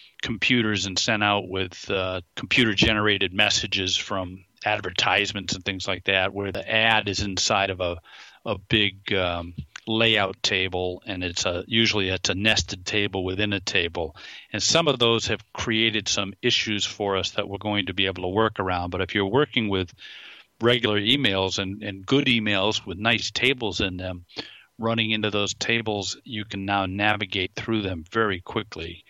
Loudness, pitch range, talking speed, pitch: -23 LUFS, 95-110 Hz, 175 wpm, 100 Hz